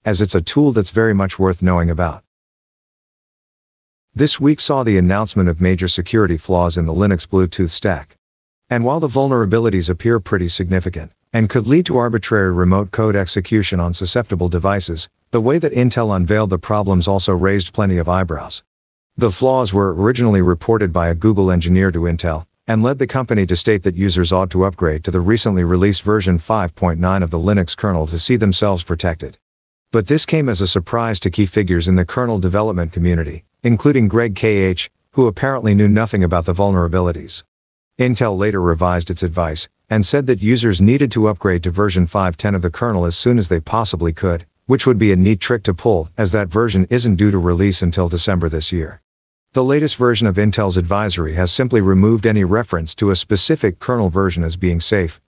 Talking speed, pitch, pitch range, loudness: 190 wpm, 95 Hz, 90-110 Hz, -16 LUFS